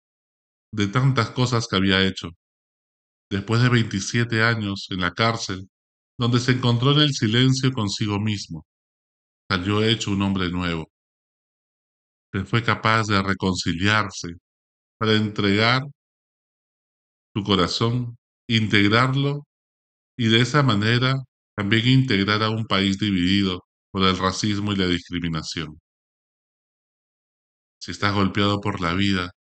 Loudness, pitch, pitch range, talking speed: -21 LUFS, 100 Hz, 90-115 Hz, 120 wpm